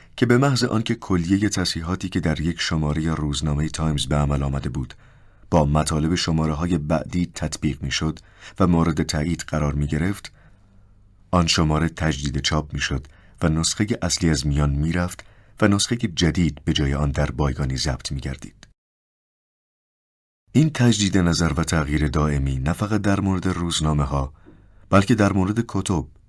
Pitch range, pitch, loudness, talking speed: 75-100 Hz, 85 Hz, -22 LUFS, 160 wpm